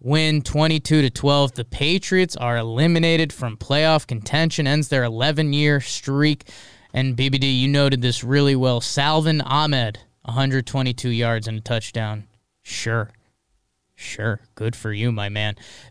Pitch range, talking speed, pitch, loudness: 115-150 Hz, 140 wpm, 135 Hz, -20 LUFS